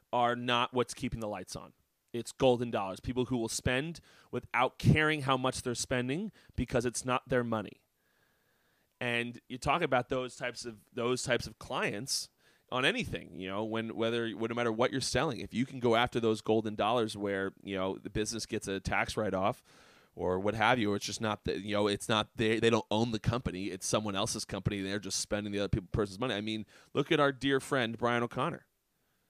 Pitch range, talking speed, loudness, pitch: 105-125 Hz, 220 wpm, -32 LUFS, 115 Hz